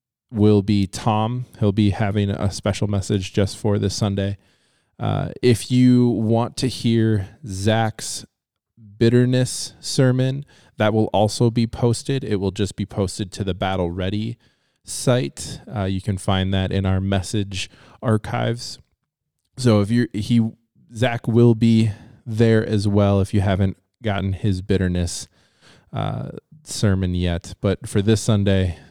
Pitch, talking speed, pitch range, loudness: 105 Hz, 145 wpm, 100-115 Hz, -21 LUFS